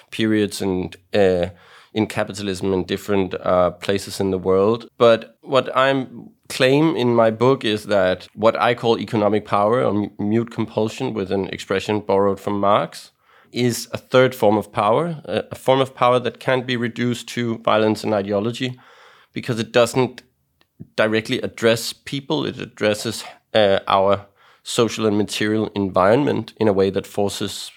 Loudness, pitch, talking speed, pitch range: -20 LUFS, 110 Hz, 155 wpm, 100-120 Hz